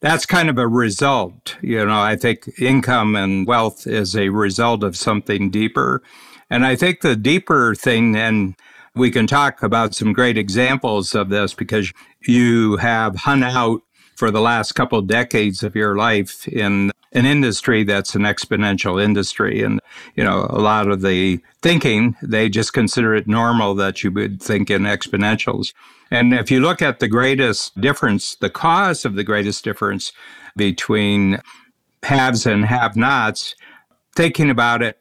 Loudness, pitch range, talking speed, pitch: -17 LUFS, 105-125 Hz, 165 wpm, 110 Hz